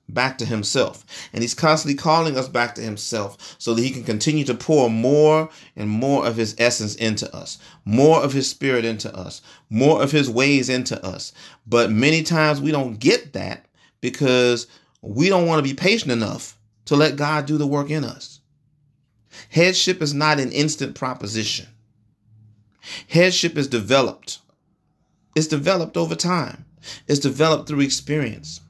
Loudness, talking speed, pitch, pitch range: -20 LUFS, 165 wpm, 135 Hz, 115-155 Hz